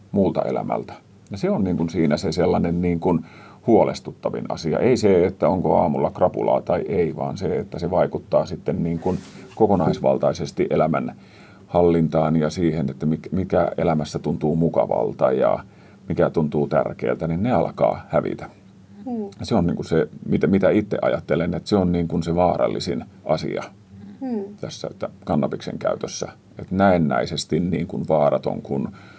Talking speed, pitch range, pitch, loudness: 155 wpm, 80-95 Hz, 85 Hz, -22 LUFS